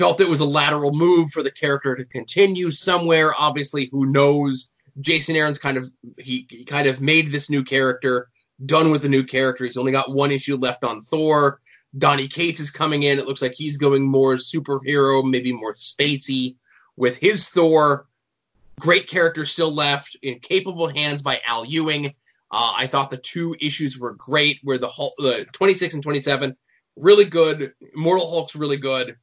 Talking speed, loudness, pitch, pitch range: 185 wpm, -20 LUFS, 140 Hz, 135-155 Hz